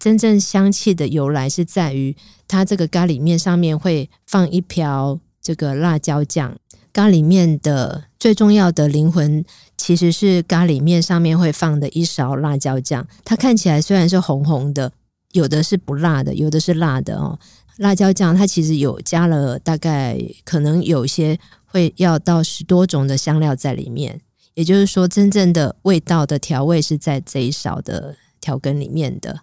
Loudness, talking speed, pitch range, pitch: -17 LUFS, 255 characters per minute, 145-180 Hz, 165 Hz